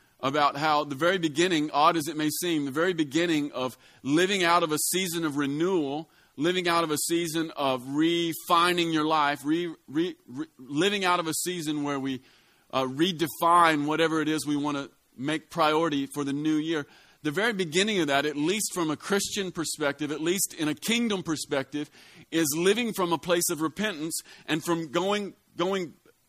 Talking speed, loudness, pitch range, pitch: 185 wpm, -27 LUFS, 150-175 Hz, 165 Hz